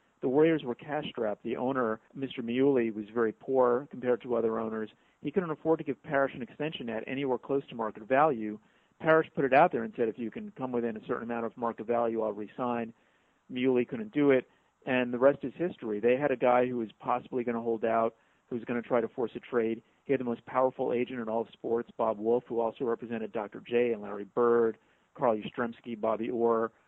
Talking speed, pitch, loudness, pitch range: 230 wpm, 120 Hz, -30 LUFS, 115-135 Hz